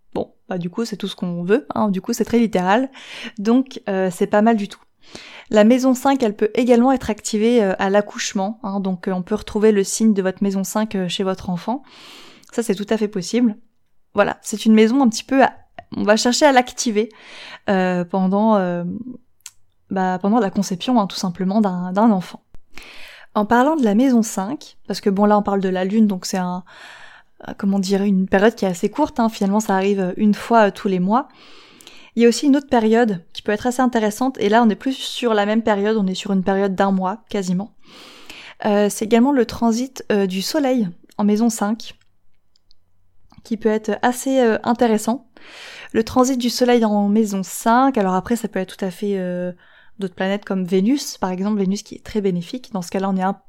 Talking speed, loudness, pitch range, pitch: 215 wpm, -19 LUFS, 195-235 Hz, 210 Hz